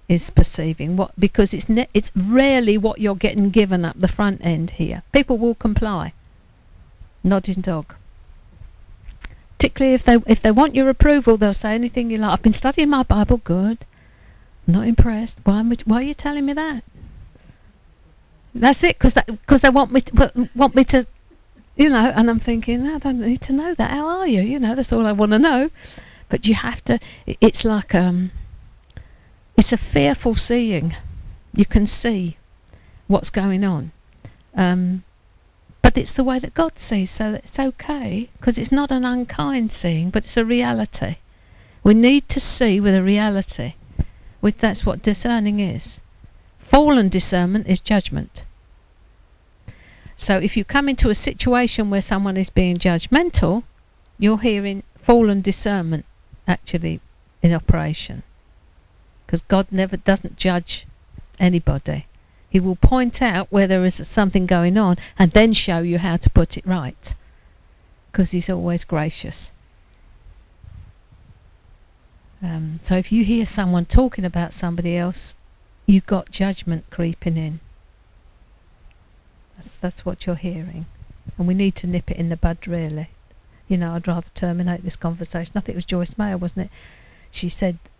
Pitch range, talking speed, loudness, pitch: 165-225 Hz, 160 wpm, -19 LUFS, 190 Hz